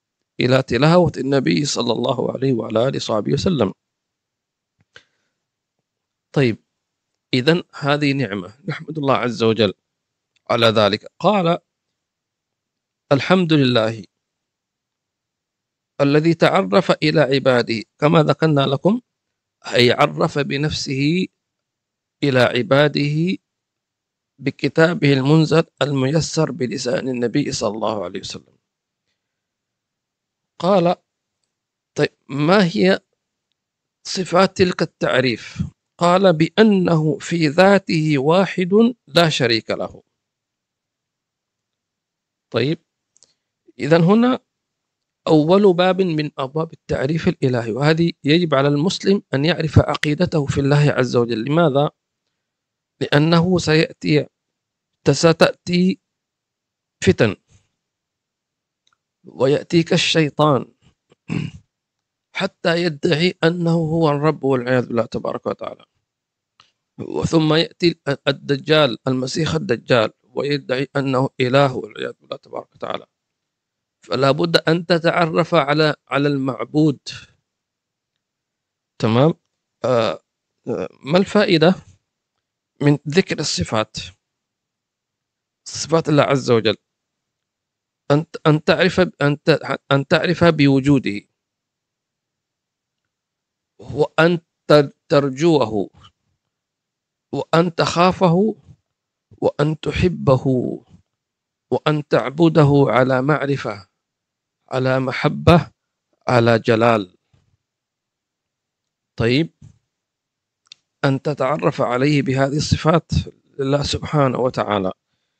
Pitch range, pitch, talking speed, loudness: 130-165 Hz, 150 Hz, 80 wpm, -18 LUFS